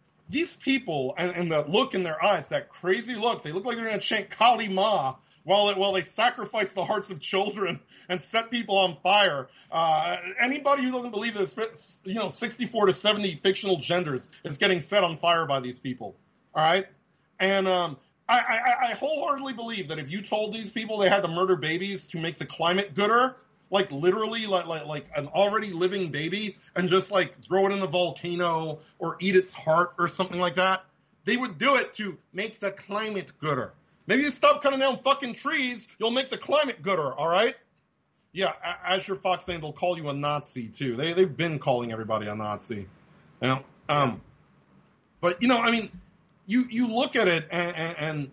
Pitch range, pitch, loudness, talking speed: 165-220 Hz, 190 Hz, -26 LUFS, 195 wpm